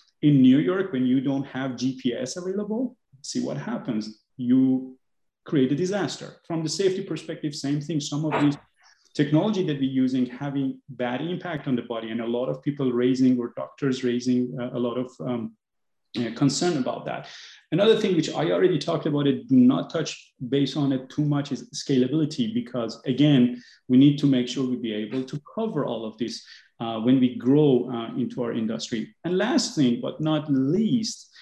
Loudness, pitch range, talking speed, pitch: -25 LUFS, 125-155 Hz, 190 wpm, 135 Hz